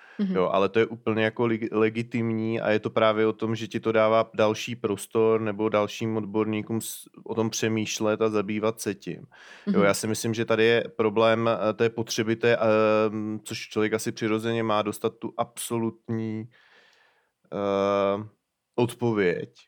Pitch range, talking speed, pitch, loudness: 110-115 Hz, 150 wpm, 110 Hz, -25 LUFS